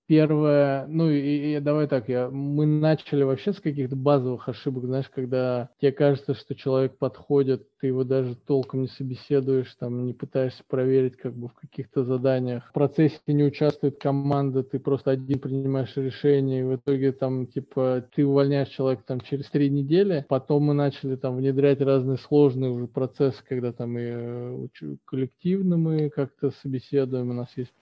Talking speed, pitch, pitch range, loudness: 165 wpm, 135 Hz, 130-145 Hz, -25 LUFS